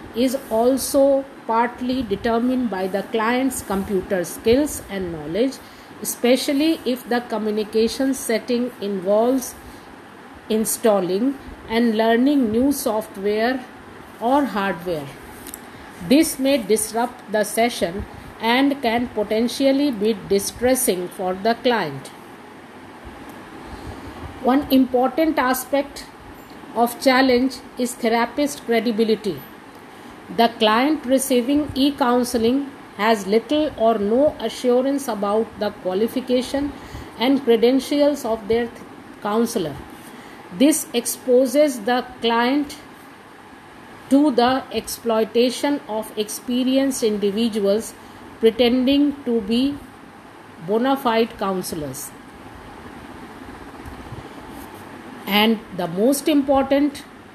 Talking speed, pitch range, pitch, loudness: 90 wpm, 220-270 Hz, 240 Hz, -20 LUFS